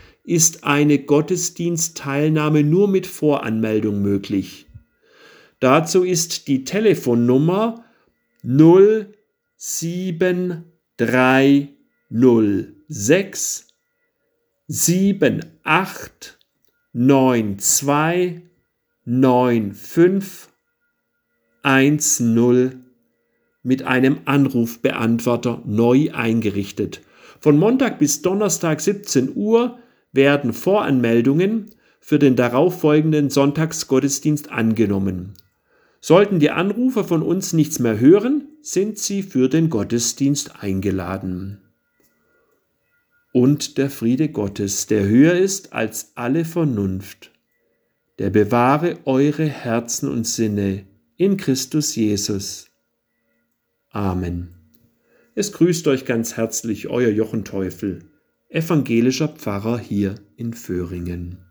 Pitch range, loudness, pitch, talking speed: 115-170 Hz, -18 LUFS, 135 Hz, 80 wpm